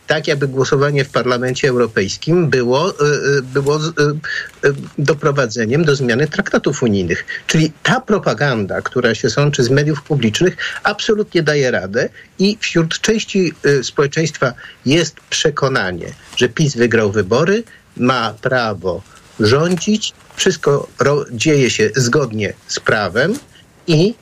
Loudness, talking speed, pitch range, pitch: -16 LUFS, 110 wpm, 130-170 Hz, 145 Hz